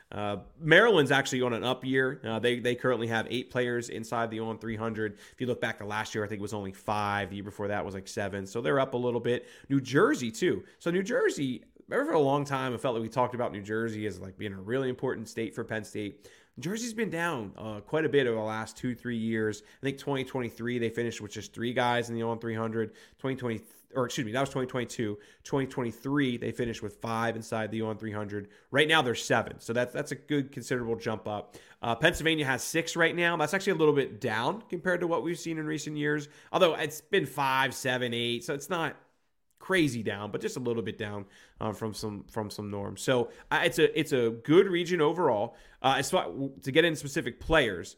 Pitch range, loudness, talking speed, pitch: 110-140 Hz, -30 LUFS, 235 wpm, 120 Hz